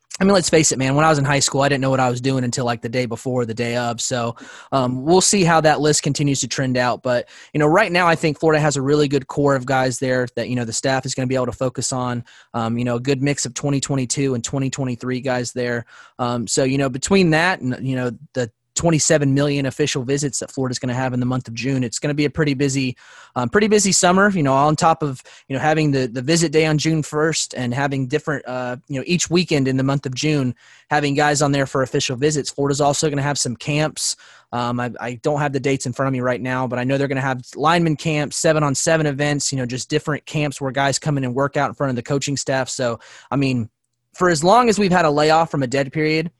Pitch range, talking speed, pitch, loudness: 125-150 Hz, 280 wpm, 140 Hz, -19 LUFS